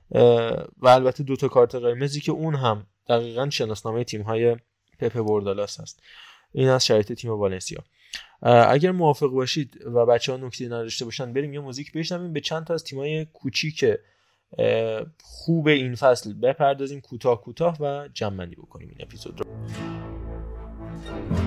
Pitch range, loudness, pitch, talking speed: 115-145 Hz, -23 LUFS, 125 Hz, 150 wpm